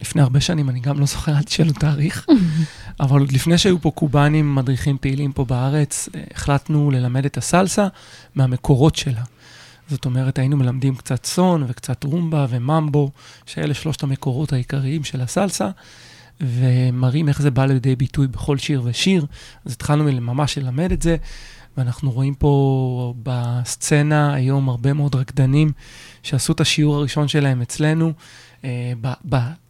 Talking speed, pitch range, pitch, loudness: 150 wpm, 130-150 Hz, 140 Hz, -19 LUFS